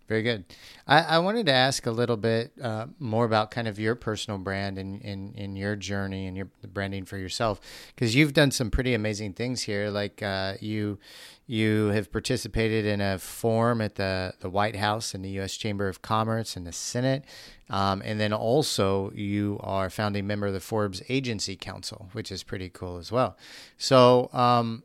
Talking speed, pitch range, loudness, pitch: 195 wpm, 100-115 Hz, -27 LUFS, 105 Hz